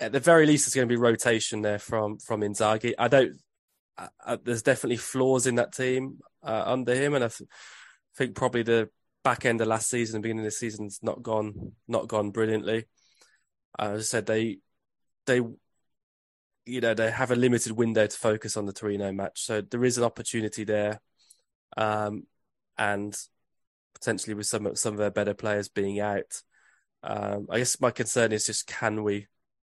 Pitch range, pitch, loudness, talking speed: 105-120 Hz, 110 Hz, -27 LUFS, 185 wpm